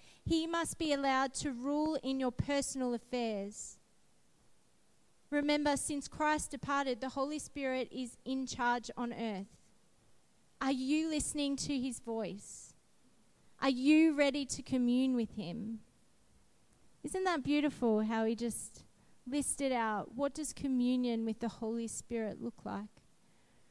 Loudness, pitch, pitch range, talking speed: -35 LUFS, 260 Hz, 230-285 Hz, 130 wpm